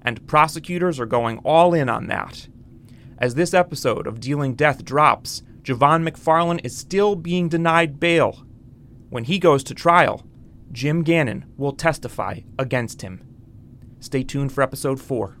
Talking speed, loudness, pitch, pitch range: 150 wpm, -20 LUFS, 135 Hz, 125-165 Hz